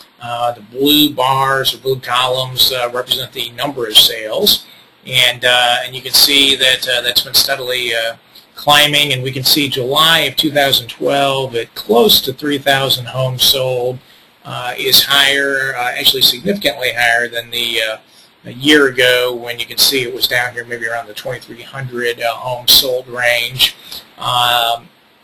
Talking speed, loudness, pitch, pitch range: 165 wpm, -12 LUFS, 125 Hz, 120-135 Hz